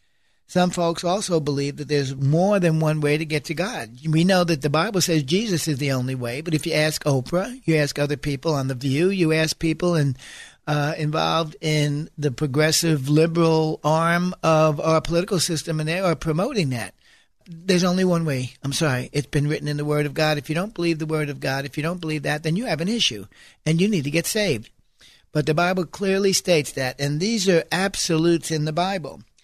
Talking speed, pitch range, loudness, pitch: 220 wpm, 145-170 Hz, -22 LUFS, 160 Hz